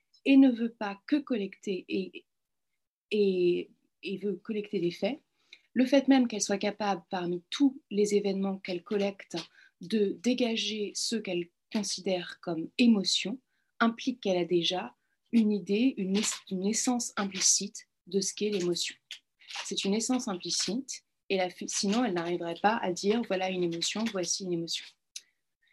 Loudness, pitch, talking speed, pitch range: -30 LUFS, 200 Hz, 145 wpm, 185-230 Hz